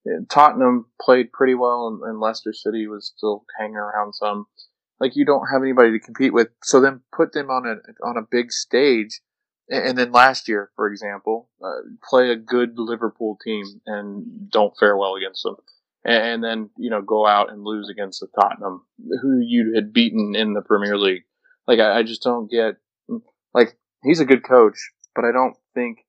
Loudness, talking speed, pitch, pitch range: -19 LUFS, 190 wpm, 115 Hz, 105-125 Hz